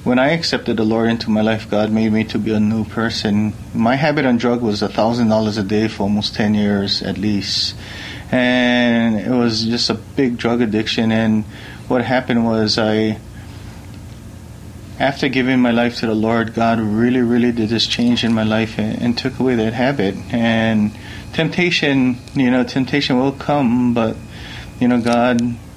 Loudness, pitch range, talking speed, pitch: -17 LUFS, 110-120 Hz, 175 wpm, 115 Hz